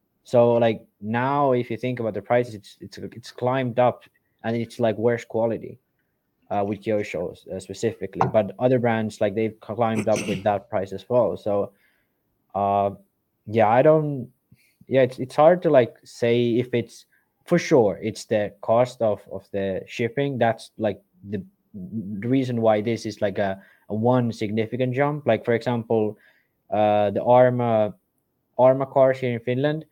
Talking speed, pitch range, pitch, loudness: 170 wpm, 110-125 Hz, 115 Hz, -23 LUFS